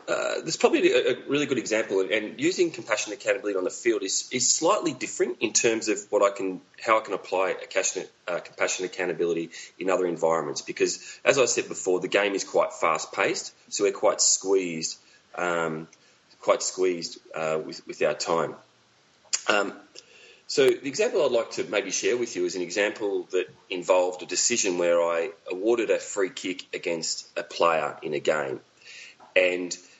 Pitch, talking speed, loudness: 345 Hz, 175 wpm, -26 LUFS